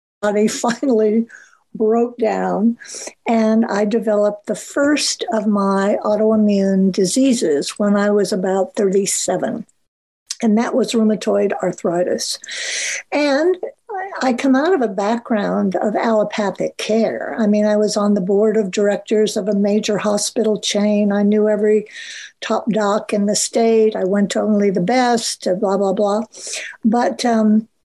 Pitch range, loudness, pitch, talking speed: 205-230 Hz, -17 LUFS, 215 Hz, 140 wpm